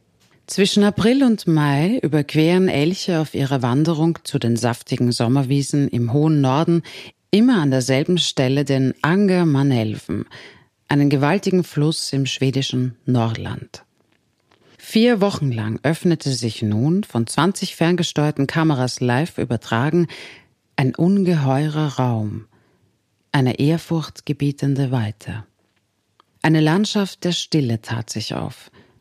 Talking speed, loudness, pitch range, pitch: 110 wpm, -19 LUFS, 120-165 Hz, 145 Hz